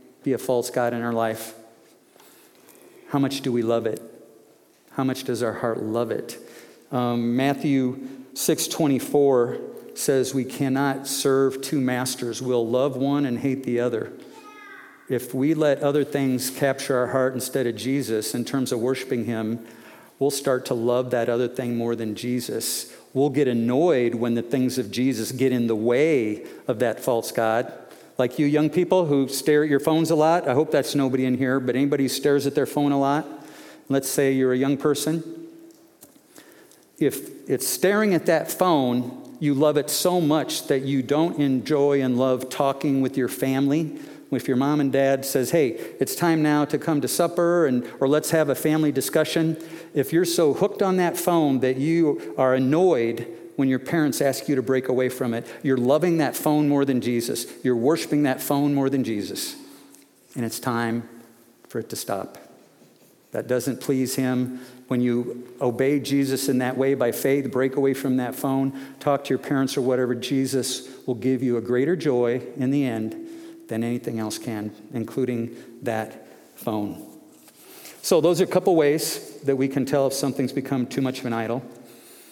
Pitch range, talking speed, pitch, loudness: 125-145 Hz, 185 wpm, 135 Hz, -23 LUFS